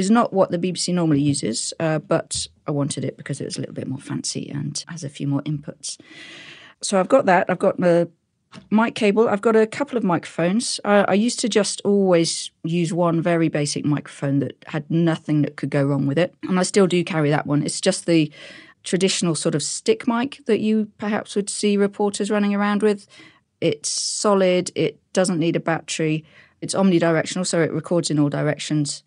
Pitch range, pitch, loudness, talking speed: 150-200 Hz, 170 Hz, -21 LUFS, 205 wpm